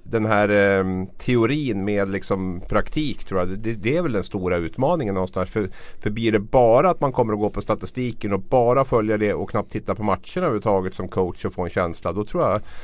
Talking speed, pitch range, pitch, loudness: 225 wpm, 95-115 Hz, 105 Hz, -22 LUFS